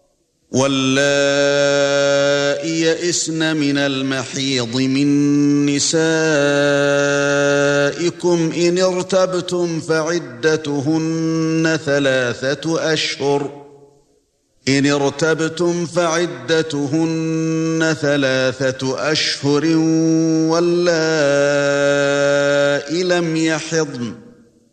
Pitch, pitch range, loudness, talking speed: 145 Hz, 140-160 Hz, -17 LUFS, 45 wpm